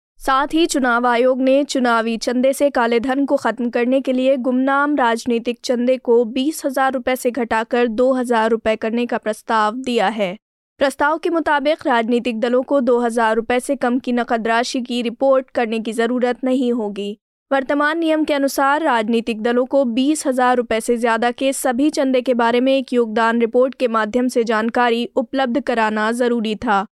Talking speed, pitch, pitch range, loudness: 180 wpm, 250 Hz, 235-270 Hz, -18 LUFS